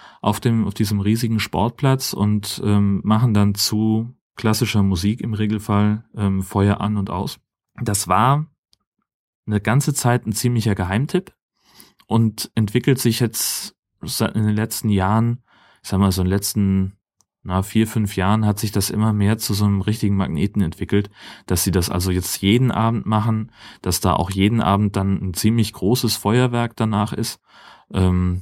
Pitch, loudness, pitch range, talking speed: 105 Hz, -20 LUFS, 100-115 Hz, 170 wpm